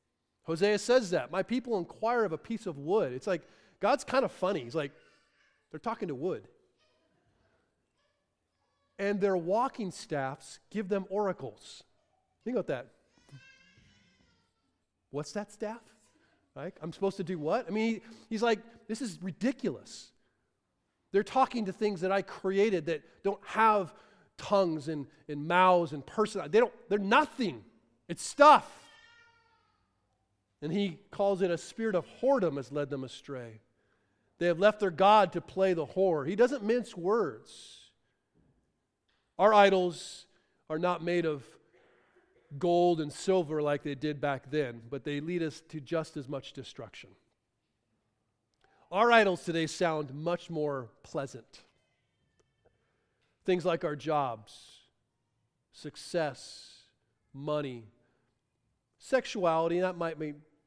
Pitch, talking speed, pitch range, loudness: 170 Hz, 135 wpm, 140-205 Hz, -30 LUFS